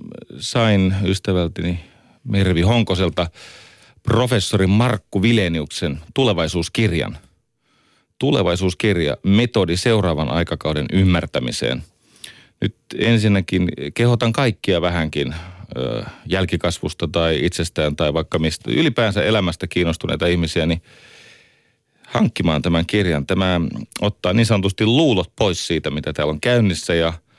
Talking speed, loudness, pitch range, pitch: 95 wpm, -19 LUFS, 85-105 Hz, 90 Hz